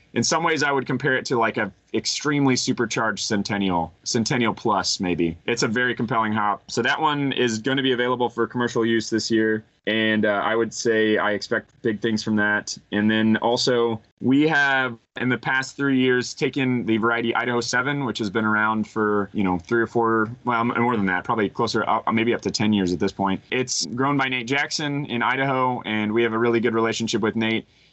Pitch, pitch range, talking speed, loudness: 115 Hz, 110-125 Hz, 215 wpm, -22 LUFS